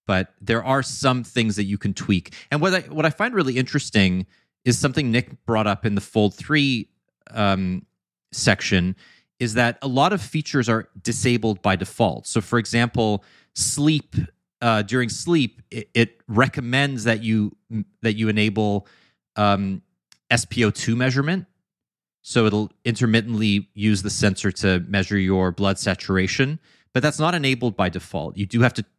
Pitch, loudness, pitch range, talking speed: 115 Hz, -22 LUFS, 100-130 Hz, 160 wpm